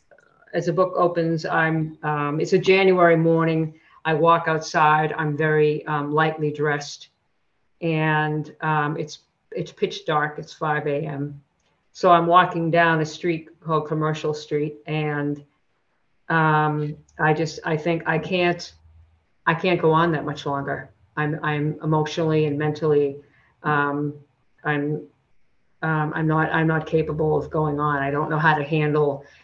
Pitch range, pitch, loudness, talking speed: 150-160 Hz, 155 Hz, -22 LUFS, 150 wpm